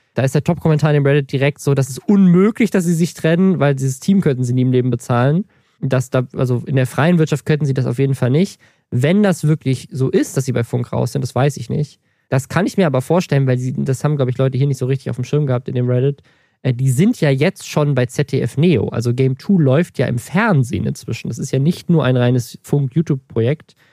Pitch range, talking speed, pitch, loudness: 130-160 Hz, 260 wpm, 140 Hz, -17 LUFS